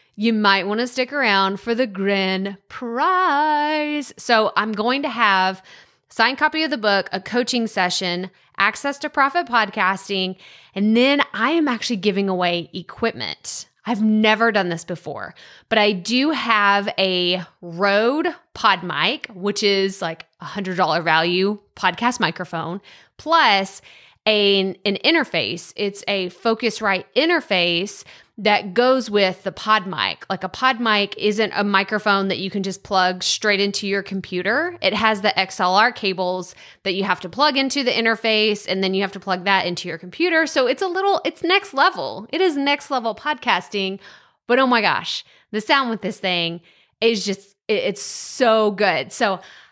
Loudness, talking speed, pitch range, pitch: -19 LUFS, 165 wpm, 190-245 Hz, 205 Hz